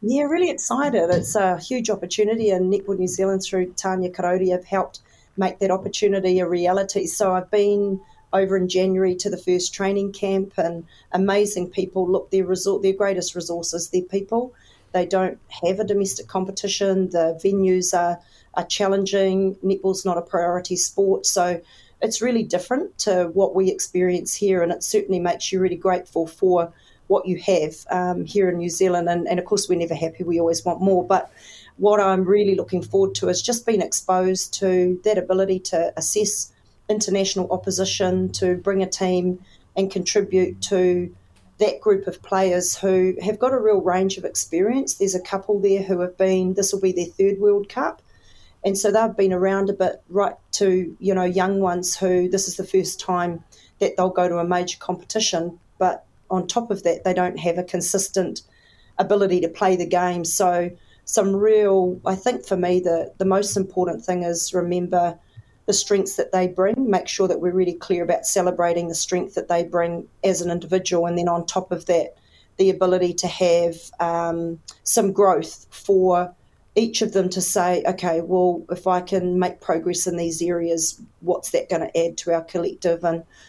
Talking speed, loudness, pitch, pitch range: 185 wpm, -21 LUFS, 185 Hz, 175-195 Hz